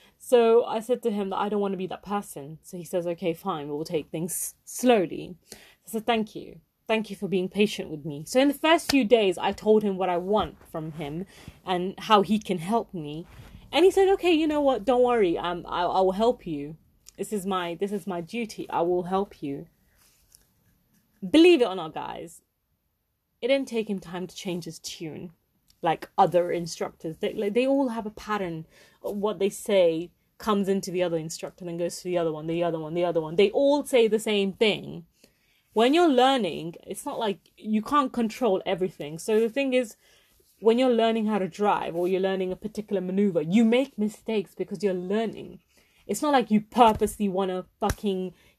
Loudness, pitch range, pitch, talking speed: -25 LUFS, 175-225 Hz, 195 Hz, 210 wpm